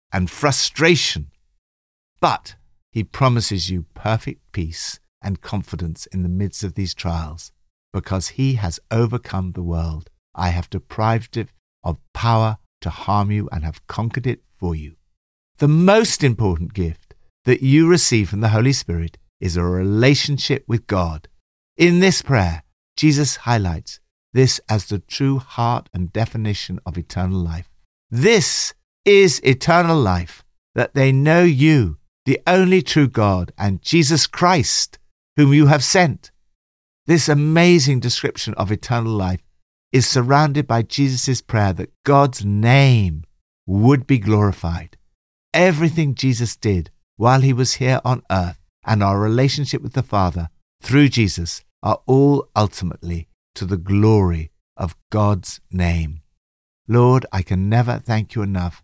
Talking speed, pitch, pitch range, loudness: 140 wpm, 105 Hz, 85-130 Hz, -18 LUFS